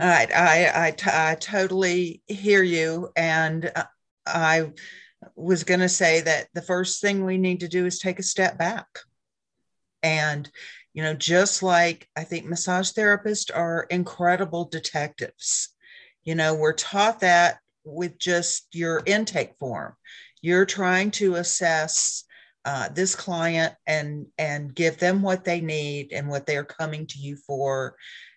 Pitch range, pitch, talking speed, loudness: 155-185 Hz, 170 Hz, 150 wpm, -23 LUFS